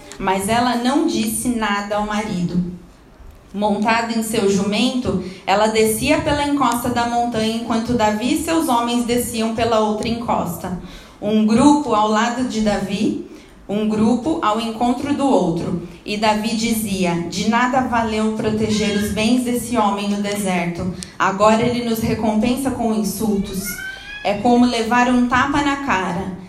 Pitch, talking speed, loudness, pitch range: 220 Hz, 145 wpm, -18 LUFS, 205-245 Hz